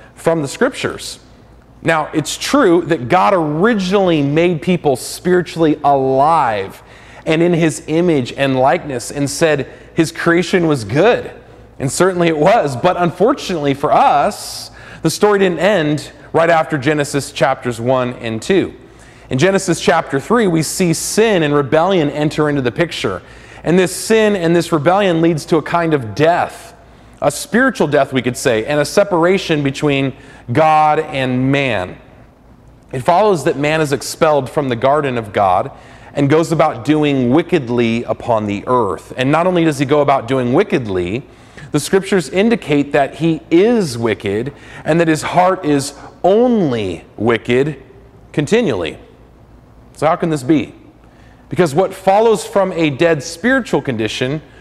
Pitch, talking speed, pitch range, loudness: 155 Hz, 150 wpm, 135-175 Hz, -15 LUFS